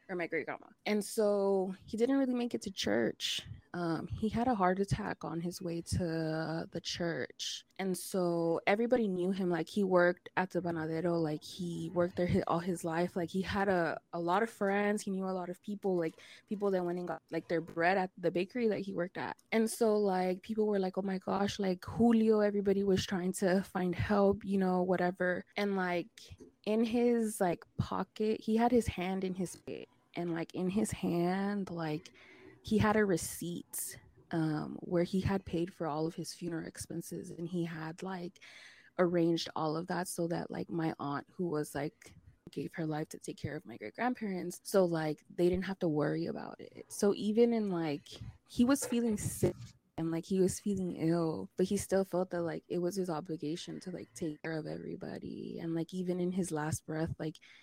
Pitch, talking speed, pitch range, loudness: 180 Hz, 210 wpm, 165-200 Hz, -34 LUFS